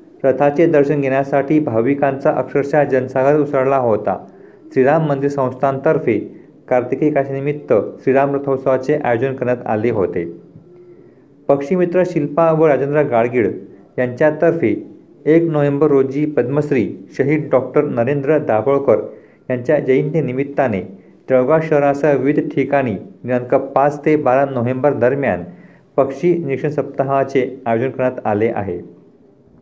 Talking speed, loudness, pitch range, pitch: 105 wpm, -16 LUFS, 130-150 Hz, 140 Hz